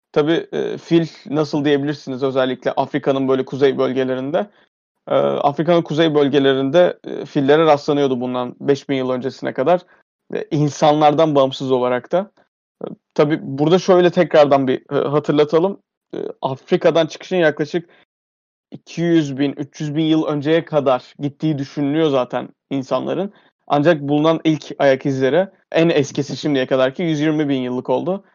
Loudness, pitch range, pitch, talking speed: -18 LUFS, 135-165 Hz, 150 Hz, 120 wpm